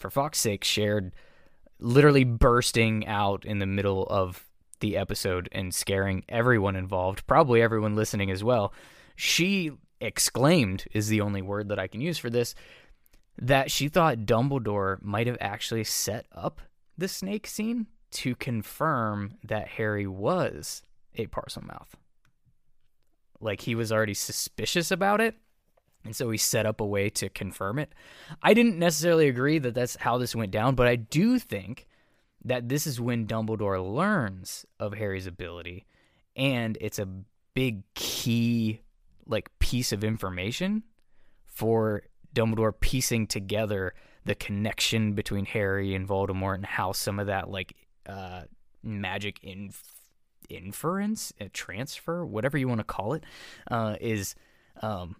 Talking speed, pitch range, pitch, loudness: 145 wpm, 100-130 Hz, 110 Hz, -27 LUFS